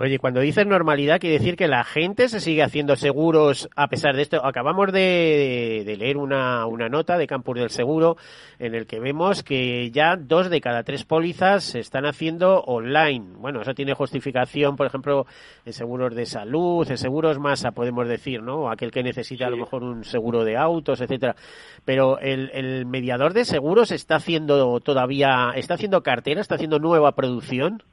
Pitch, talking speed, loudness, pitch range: 140 Hz, 185 wpm, -22 LUFS, 125-160 Hz